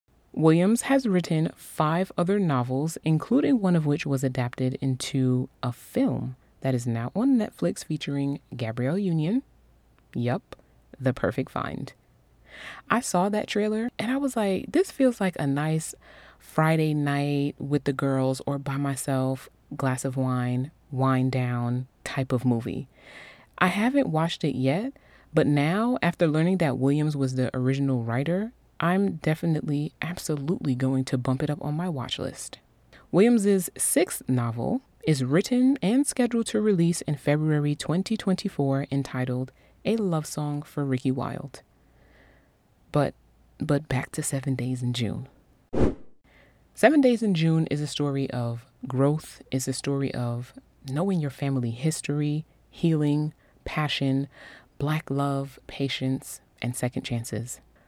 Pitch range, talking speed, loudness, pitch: 130-175 Hz, 140 wpm, -26 LUFS, 145 Hz